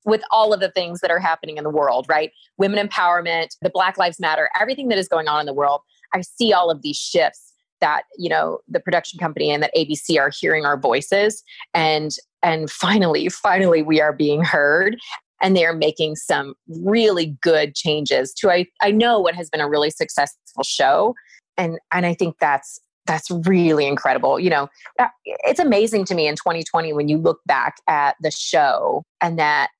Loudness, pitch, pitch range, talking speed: -19 LUFS, 165 Hz, 150-190 Hz, 195 wpm